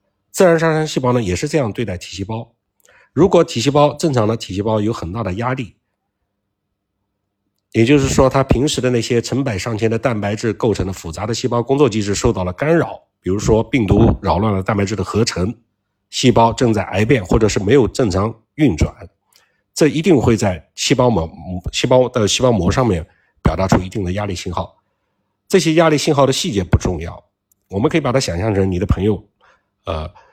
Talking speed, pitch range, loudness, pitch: 295 characters per minute, 100-130 Hz, -17 LUFS, 110 Hz